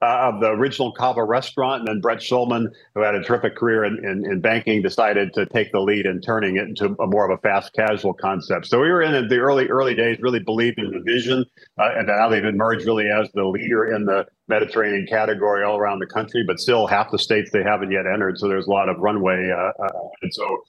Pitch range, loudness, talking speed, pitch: 105-120 Hz, -20 LUFS, 240 wpm, 110 Hz